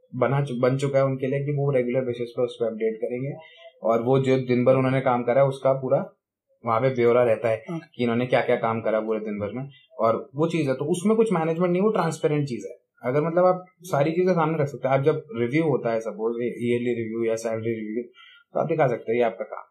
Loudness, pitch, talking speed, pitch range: -24 LUFS, 130 Hz, 245 wpm, 120-160 Hz